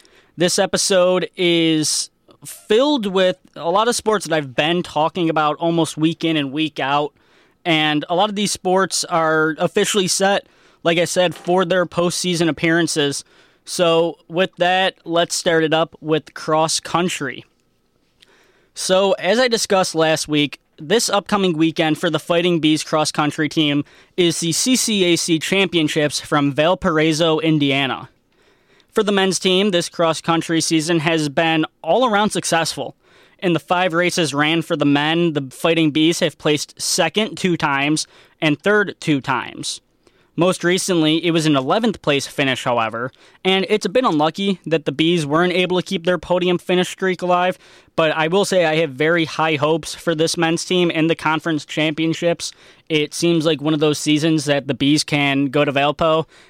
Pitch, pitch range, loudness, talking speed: 165 Hz, 155-180 Hz, -18 LUFS, 170 wpm